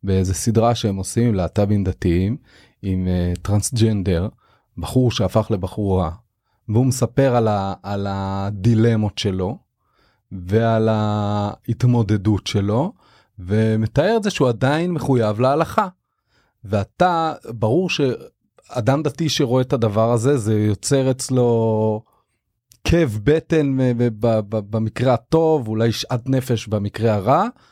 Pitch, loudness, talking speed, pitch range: 110 Hz, -19 LUFS, 105 wpm, 105-130 Hz